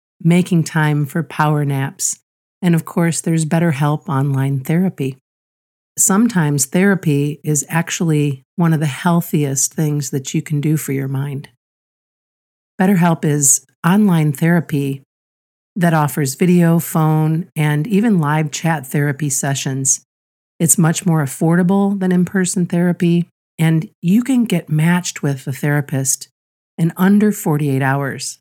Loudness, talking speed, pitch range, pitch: -16 LUFS, 130 wpm, 140-175 Hz, 155 Hz